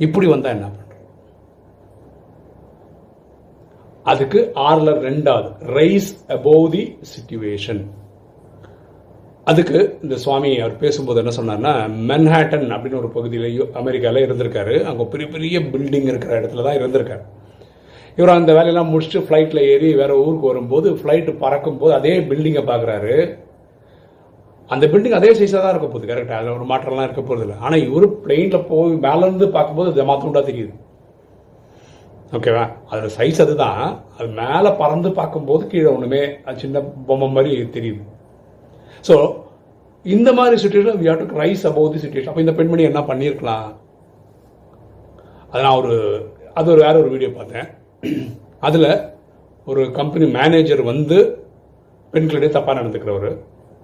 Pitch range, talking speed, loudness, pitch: 120-160 Hz, 130 wpm, -16 LUFS, 145 Hz